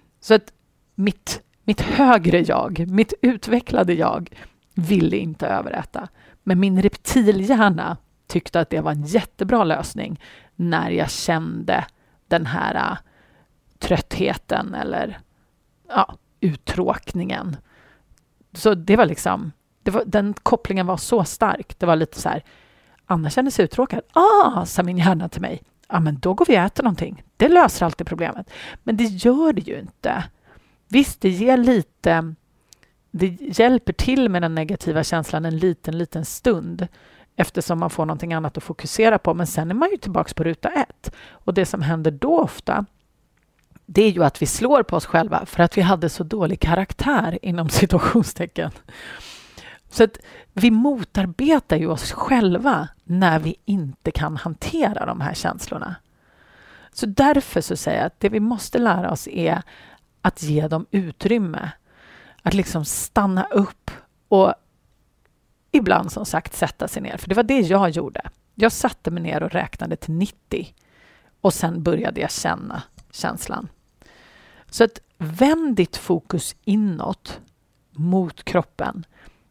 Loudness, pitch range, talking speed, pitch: -20 LUFS, 165-220 Hz, 150 wpm, 185 Hz